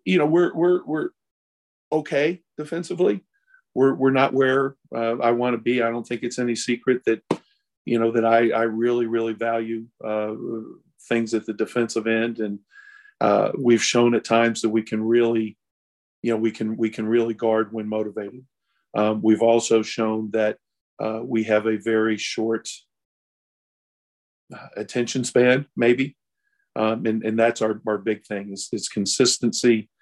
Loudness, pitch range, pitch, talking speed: -22 LUFS, 110-125 Hz, 115 Hz, 165 wpm